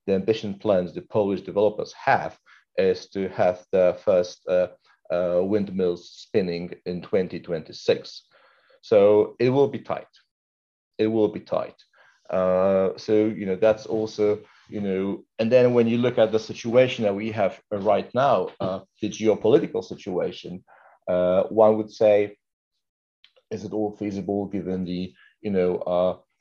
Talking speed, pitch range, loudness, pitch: 150 wpm, 95-120 Hz, -24 LUFS, 105 Hz